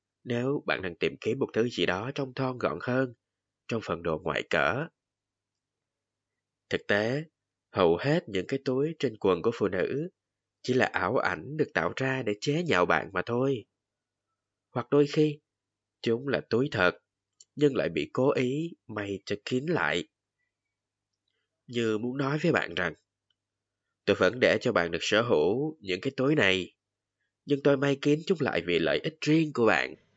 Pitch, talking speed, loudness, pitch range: 120 Hz, 175 wpm, -28 LUFS, 100-140 Hz